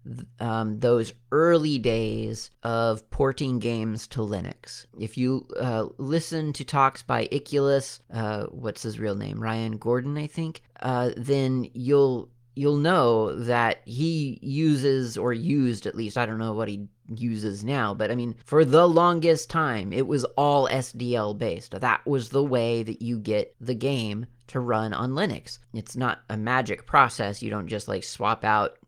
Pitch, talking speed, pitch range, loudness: 120 Hz, 170 wpm, 110-140 Hz, -25 LUFS